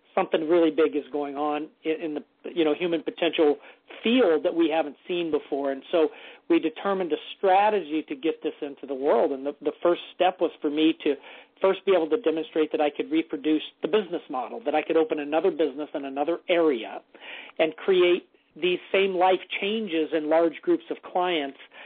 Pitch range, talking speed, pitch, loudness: 150-180 Hz, 195 wpm, 160 Hz, -25 LUFS